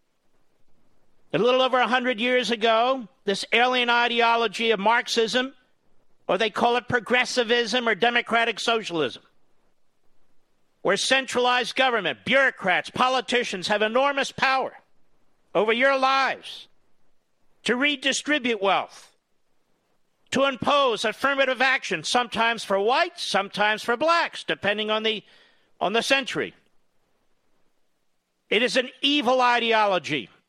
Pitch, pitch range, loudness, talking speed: 245 Hz, 225-260 Hz, -22 LUFS, 110 wpm